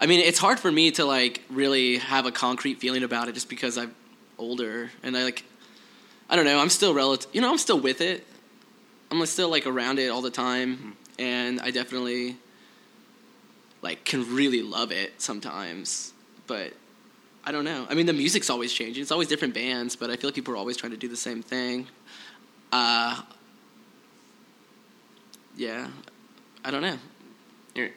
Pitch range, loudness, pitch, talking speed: 125-150 Hz, -25 LUFS, 130 Hz, 180 wpm